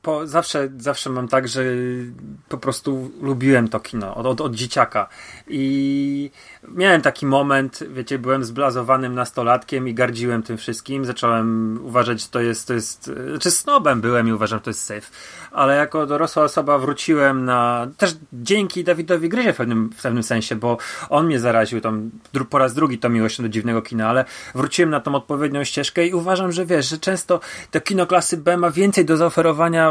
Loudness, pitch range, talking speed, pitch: -20 LUFS, 120-160 Hz, 185 wpm, 135 Hz